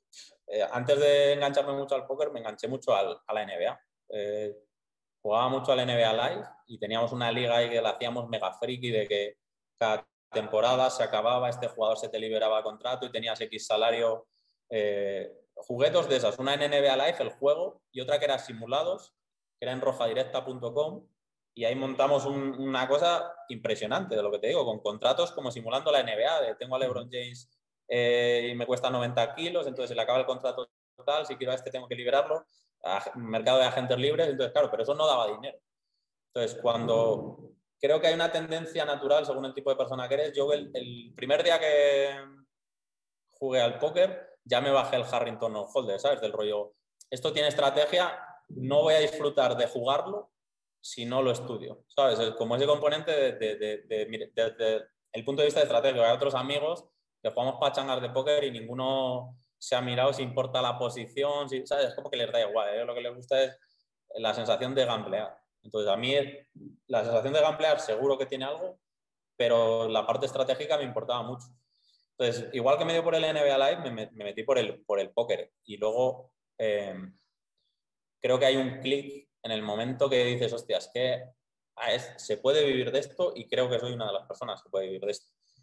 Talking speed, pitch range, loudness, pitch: 205 wpm, 115-145 Hz, -29 LUFS, 130 Hz